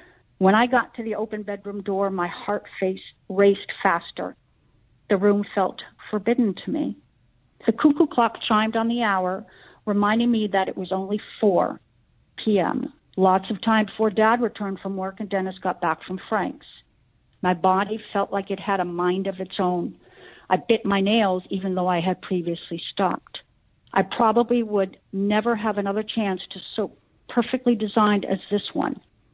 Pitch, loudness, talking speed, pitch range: 200 Hz, -23 LUFS, 170 wpm, 190-220 Hz